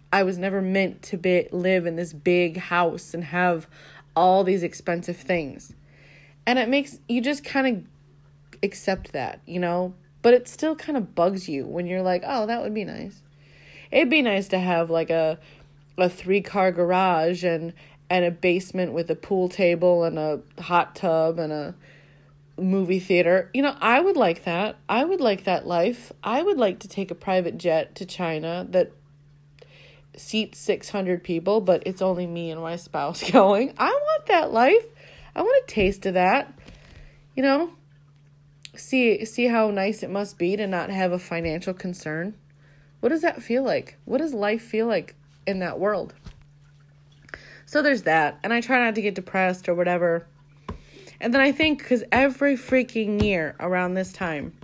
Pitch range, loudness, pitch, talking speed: 160-215 Hz, -23 LUFS, 180 Hz, 180 wpm